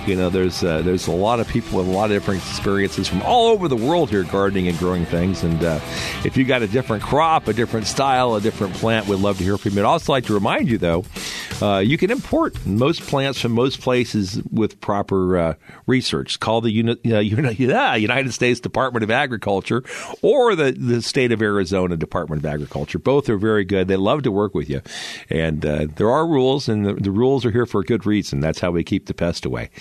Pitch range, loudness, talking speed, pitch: 90-120 Hz, -20 LUFS, 235 wpm, 105 Hz